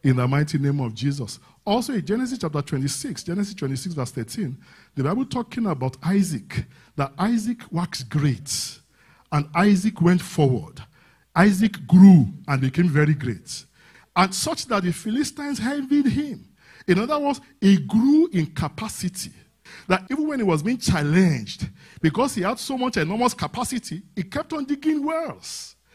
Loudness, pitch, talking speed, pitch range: -22 LUFS, 180 Hz, 155 wpm, 145-240 Hz